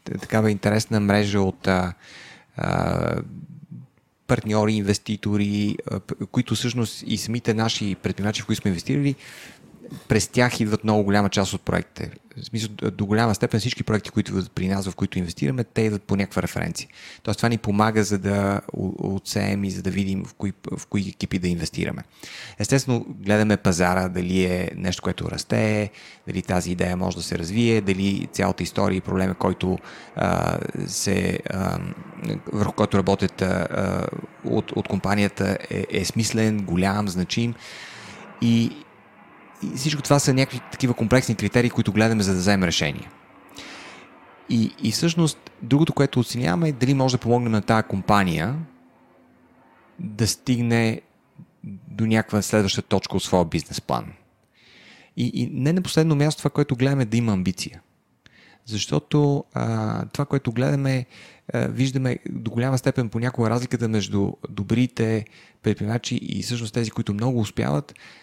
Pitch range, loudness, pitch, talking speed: 100-120 Hz, -23 LUFS, 110 Hz, 150 wpm